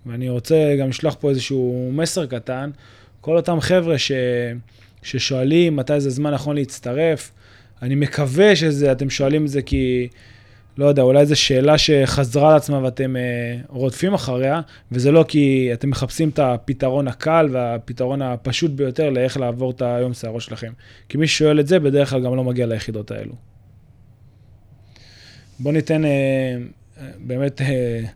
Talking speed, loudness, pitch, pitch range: 150 wpm, -19 LUFS, 130 Hz, 120-145 Hz